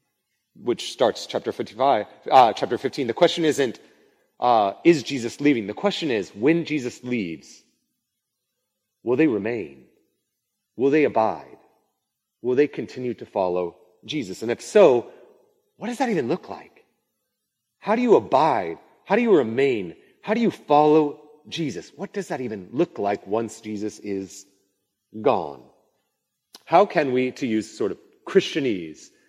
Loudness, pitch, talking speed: -22 LUFS, 150 Hz, 150 wpm